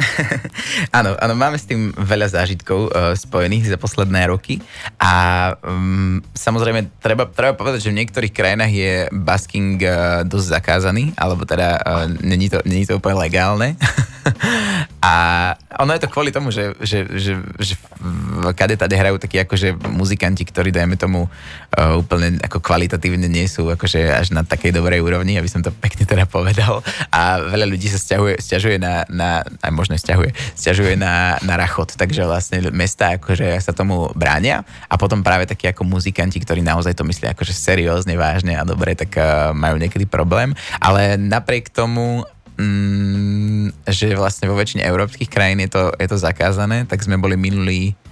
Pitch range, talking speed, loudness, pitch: 90-100 Hz, 160 wpm, -17 LUFS, 95 Hz